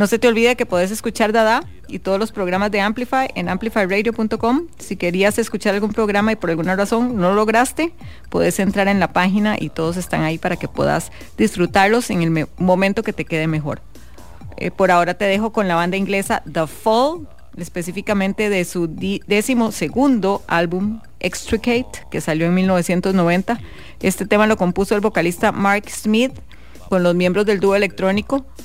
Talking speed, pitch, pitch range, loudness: 175 wpm, 200 Hz, 180-225 Hz, -18 LUFS